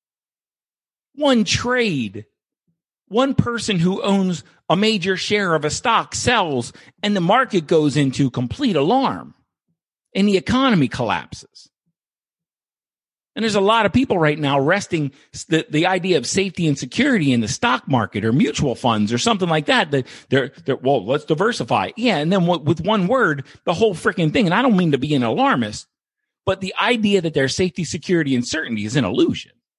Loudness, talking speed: -19 LUFS, 175 wpm